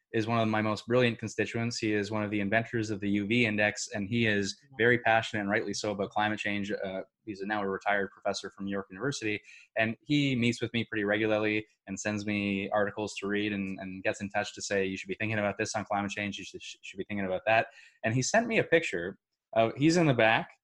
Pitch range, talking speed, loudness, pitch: 100-115 Hz, 245 wpm, -30 LUFS, 105 Hz